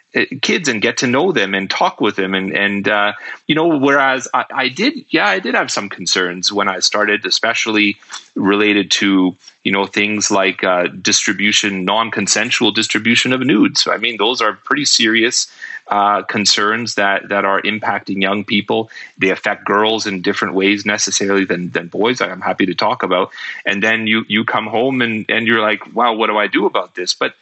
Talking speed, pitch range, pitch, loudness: 200 wpm, 100-110 Hz, 100 Hz, -15 LUFS